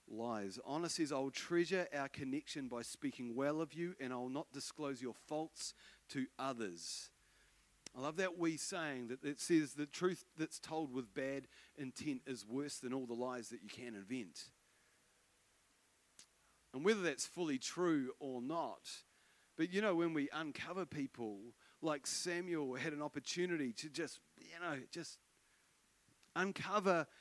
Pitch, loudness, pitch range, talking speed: 145 Hz, -42 LUFS, 130-170 Hz, 150 wpm